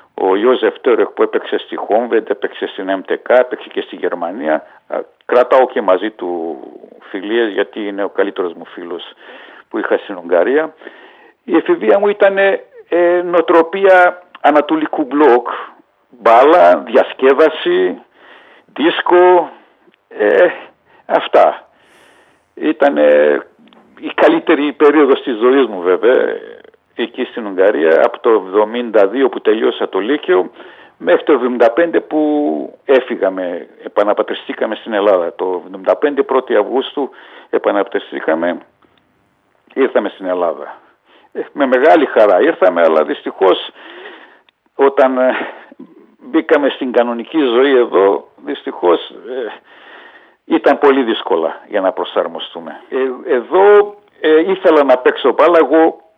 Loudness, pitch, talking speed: -13 LUFS, 355 Hz, 110 wpm